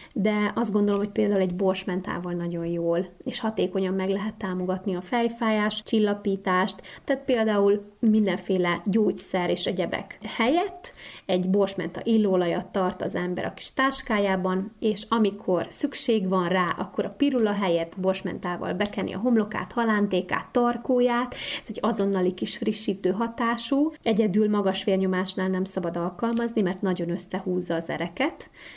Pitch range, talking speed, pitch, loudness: 185-225 Hz, 135 wpm, 200 Hz, -26 LUFS